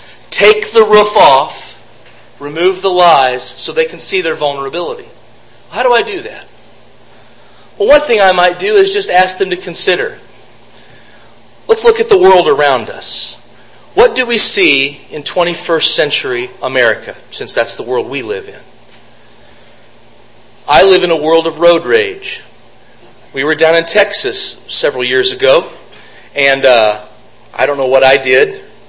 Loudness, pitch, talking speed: -10 LUFS, 185 Hz, 160 wpm